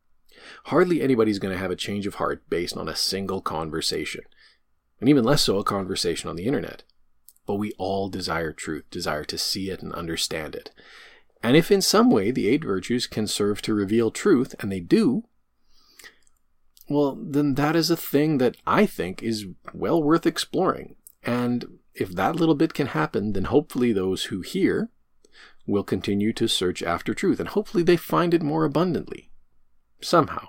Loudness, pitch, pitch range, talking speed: -24 LUFS, 115 Hz, 95-160 Hz, 175 wpm